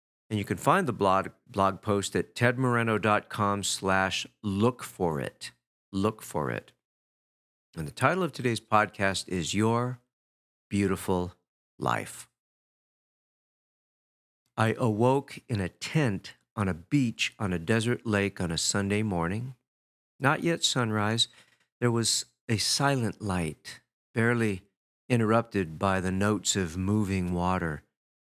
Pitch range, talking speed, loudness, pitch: 90-120 Hz, 125 wpm, -28 LUFS, 100 Hz